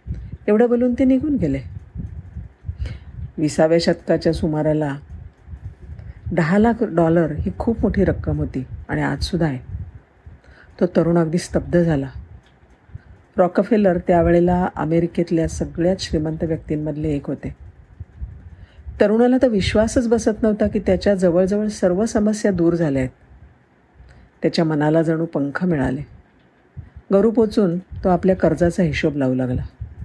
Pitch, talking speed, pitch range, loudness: 165 Hz, 115 wpm, 115-185 Hz, -19 LUFS